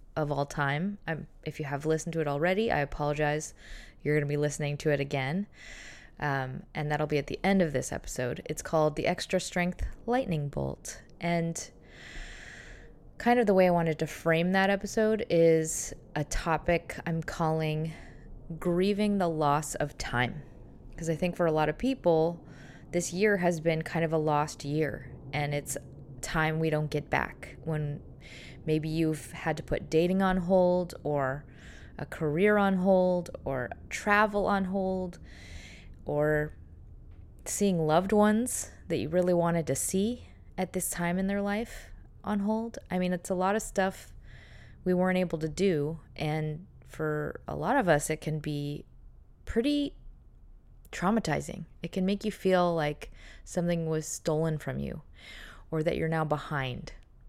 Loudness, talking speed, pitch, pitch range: -30 LUFS, 165 wpm, 160 Hz, 150-185 Hz